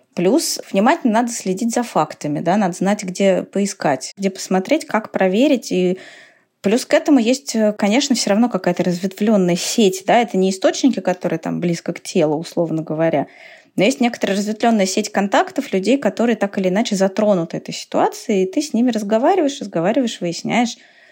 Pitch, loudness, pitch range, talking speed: 210 Hz, -18 LUFS, 190-250 Hz, 170 wpm